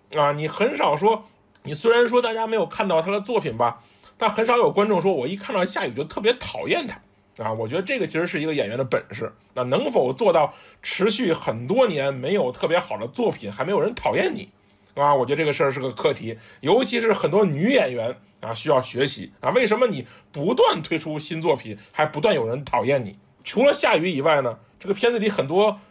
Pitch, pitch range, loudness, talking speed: 195 Hz, 145-225 Hz, -22 LUFS, 325 characters per minute